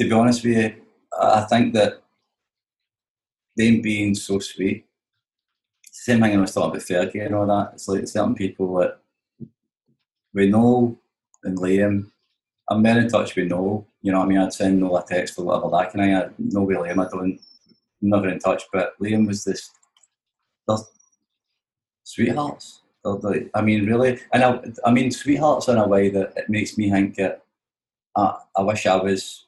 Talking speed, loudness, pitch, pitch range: 185 wpm, -21 LUFS, 100 Hz, 95-110 Hz